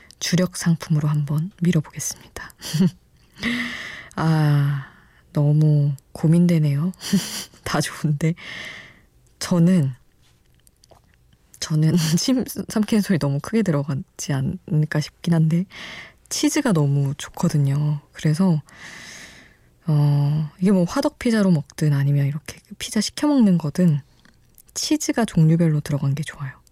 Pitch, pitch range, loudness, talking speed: 160 Hz, 145-180 Hz, -21 LUFS, 230 characters per minute